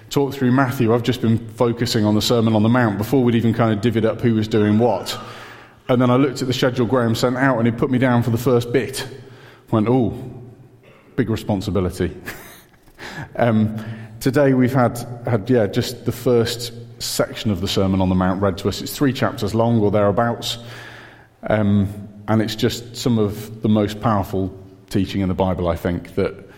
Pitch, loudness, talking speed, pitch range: 115 Hz, -19 LUFS, 200 wpm, 105-125 Hz